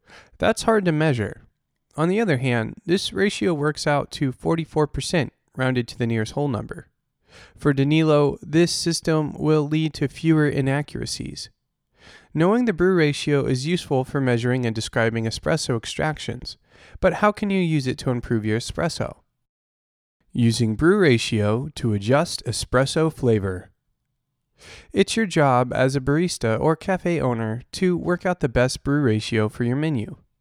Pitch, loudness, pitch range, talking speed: 140 Hz, -22 LUFS, 120-160 Hz, 150 wpm